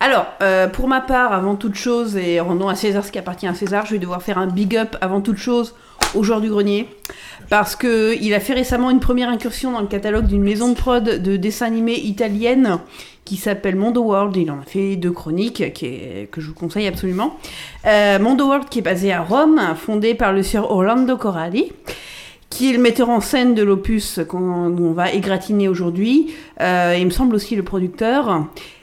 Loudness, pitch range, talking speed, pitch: -18 LUFS, 190-240 Hz, 210 wpm, 210 Hz